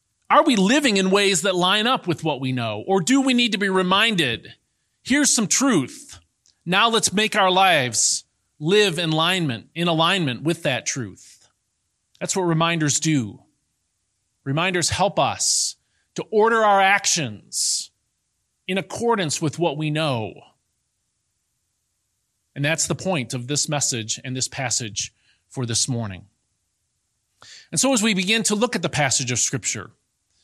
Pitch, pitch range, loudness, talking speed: 165 Hz, 125-195 Hz, -20 LUFS, 150 wpm